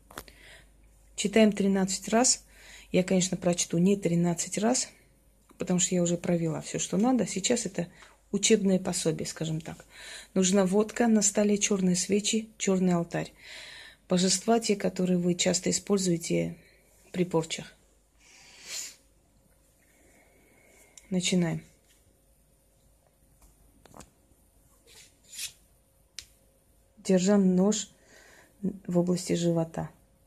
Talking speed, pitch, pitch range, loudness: 90 wpm, 190 Hz, 175-205 Hz, -27 LUFS